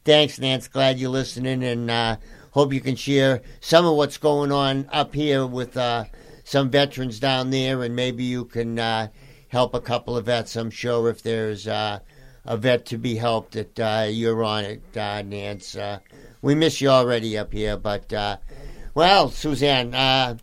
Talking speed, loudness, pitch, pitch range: 185 wpm, -22 LUFS, 125 Hz, 115-135 Hz